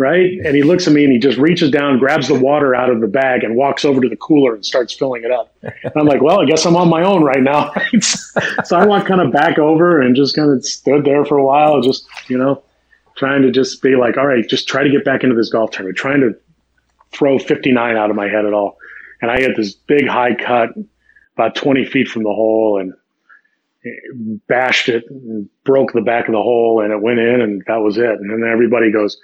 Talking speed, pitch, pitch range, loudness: 250 wpm, 130 Hz, 115-145 Hz, -14 LUFS